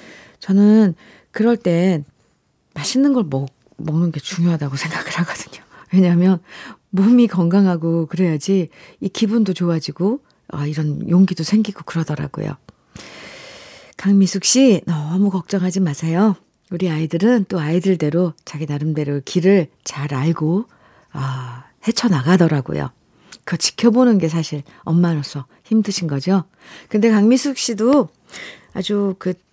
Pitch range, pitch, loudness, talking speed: 155-200 Hz, 175 Hz, -18 LUFS, 275 characters per minute